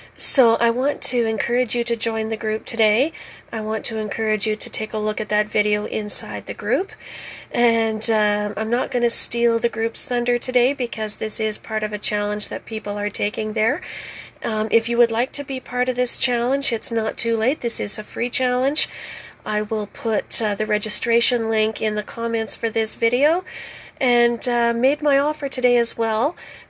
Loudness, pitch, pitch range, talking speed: -21 LUFS, 230 Hz, 215-245 Hz, 200 wpm